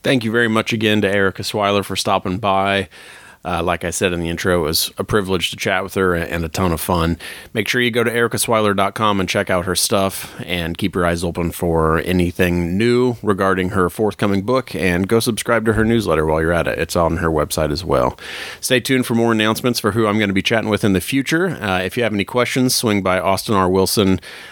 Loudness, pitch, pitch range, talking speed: -18 LUFS, 100 Hz, 90-115 Hz, 235 wpm